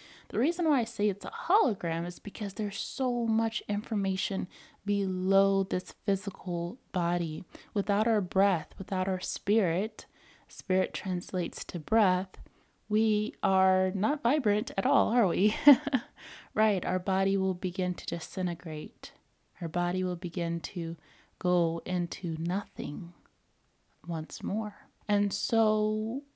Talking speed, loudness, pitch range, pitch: 125 wpm, -30 LUFS, 180-215 Hz, 195 Hz